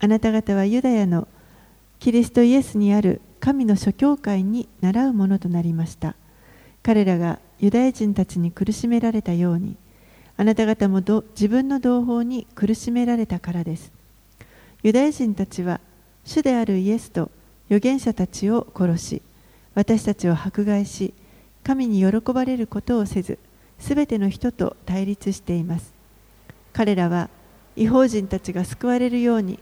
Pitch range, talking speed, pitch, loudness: 185-235 Hz, 295 characters per minute, 210 Hz, -21 LUFS